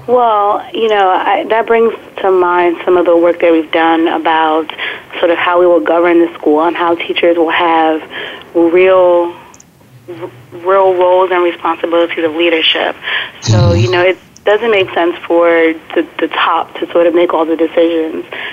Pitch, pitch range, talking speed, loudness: 170 Hz, 165-180 Hz, 175 wpm, -11 LUFS